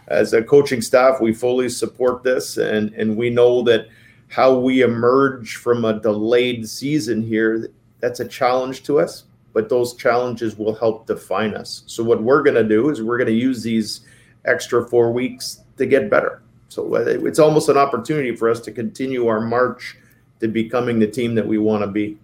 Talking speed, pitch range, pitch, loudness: 190 wpm, 110-130 Hz, 120 Hz, -18 LUFS